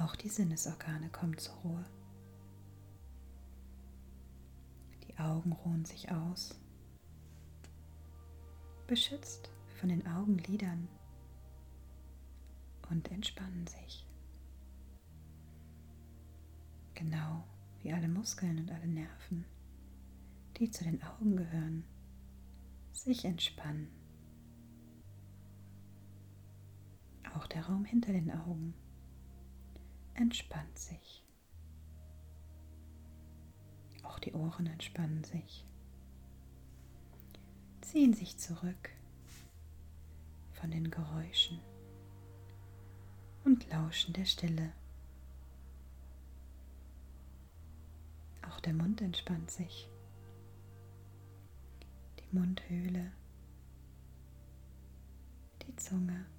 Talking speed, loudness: 70 wpm, -38 LUFS